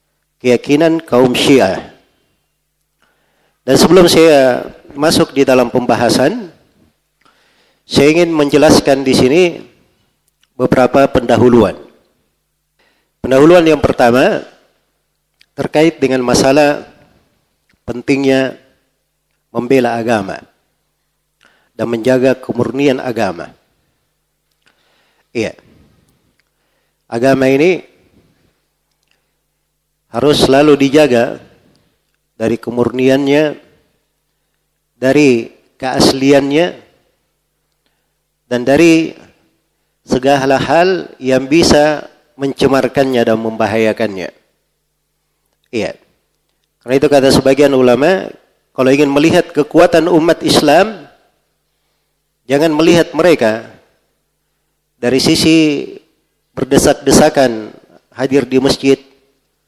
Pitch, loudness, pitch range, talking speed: 135 Hz, -11 LUFS, 125-150 Hz, 70 wpm